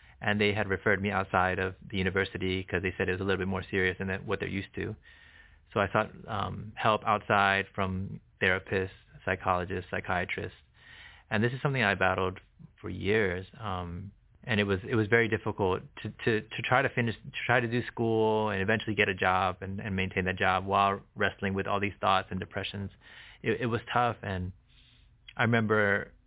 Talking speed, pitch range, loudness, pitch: 195 wpm, 95-110 Hz, -29 LUFS, 100 Hz